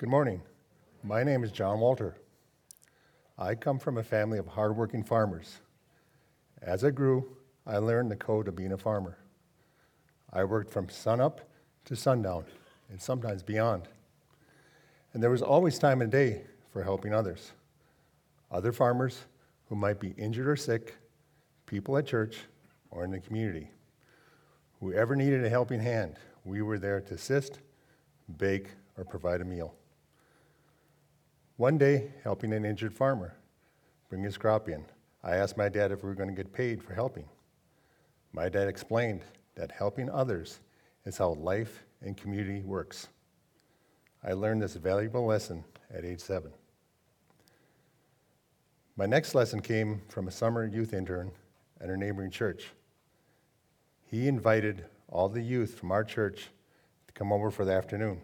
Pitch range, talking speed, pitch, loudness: 95-125 Hz, 150 wpm, 110 Hz, -31 LUFS